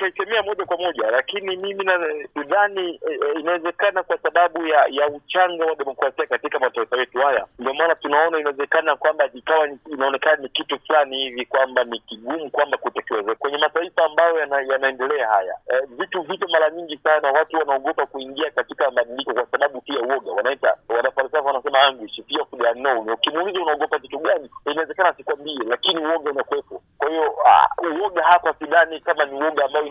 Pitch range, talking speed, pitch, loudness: 135-175 Hz, 155 wpm, 155 Hz, -20 LUFS